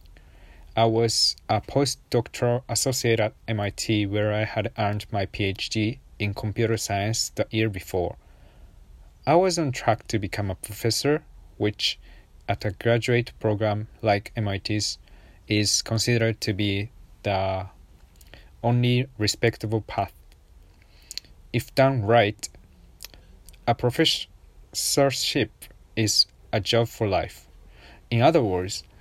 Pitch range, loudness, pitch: 90-115 Hz, -24 LUFS, 105 Hz